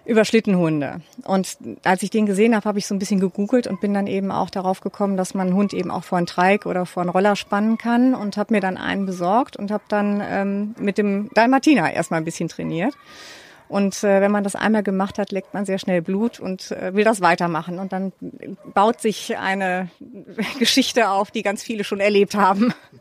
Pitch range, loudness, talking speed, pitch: 190-220 Hz, -20 LUFS, 210 wpm, 200 Hz